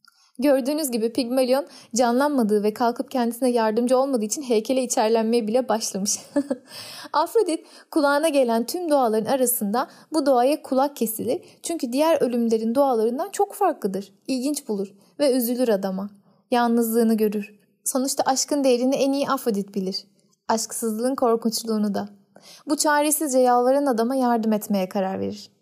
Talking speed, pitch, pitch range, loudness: 130 wpm, 245 Hz, 215-275 Hz, -22 LUFS